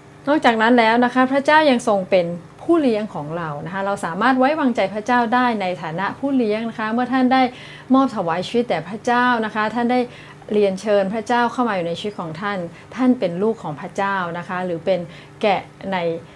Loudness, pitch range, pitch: -19 LUFS, 180-245 Hz, 215 Hz